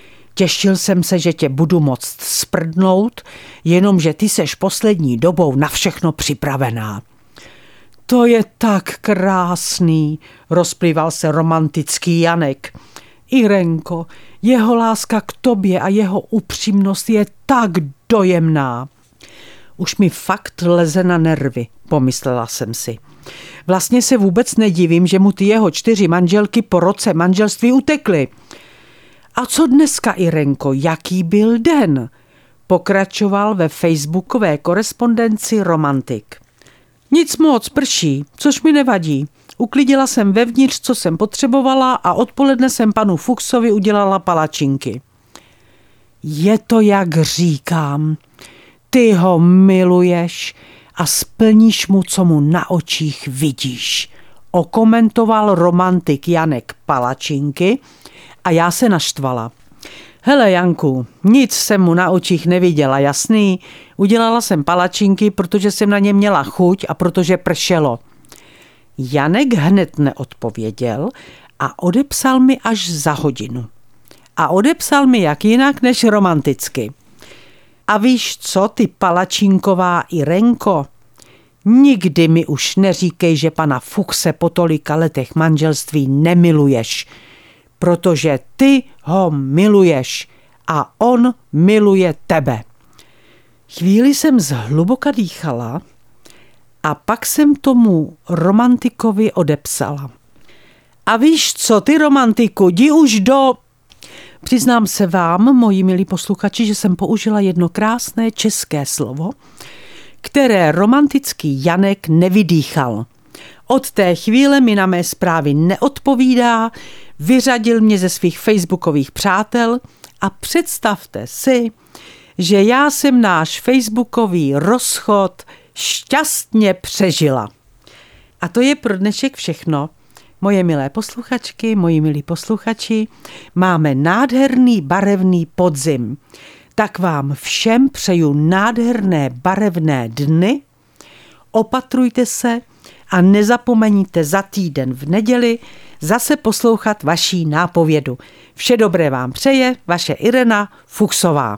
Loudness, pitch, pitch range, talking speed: -14 LUFS, 185 Hz, 155-225 Hz, 110 wpm